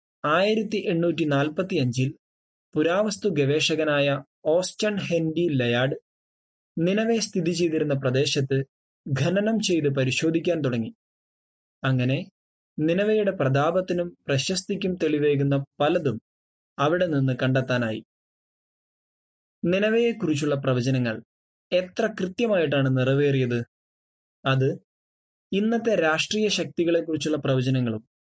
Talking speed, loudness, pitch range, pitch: 75 wpm, -24 LUFS, 130-185 Hz, 155 Hz